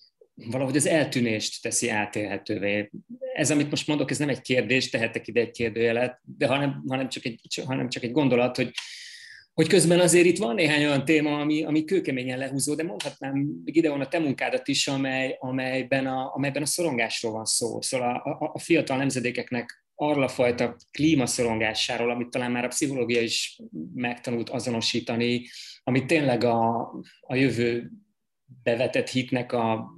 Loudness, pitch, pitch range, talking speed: -25 LUFS, 130 Hz, 120-150 Hz, 165 wpm